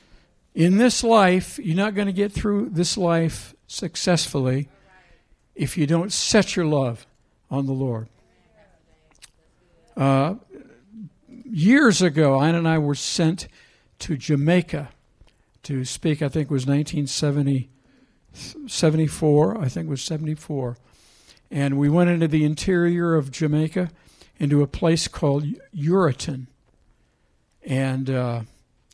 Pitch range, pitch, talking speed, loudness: 135-175 Hz, 155 Hz, 120 wpm, -22 LUFS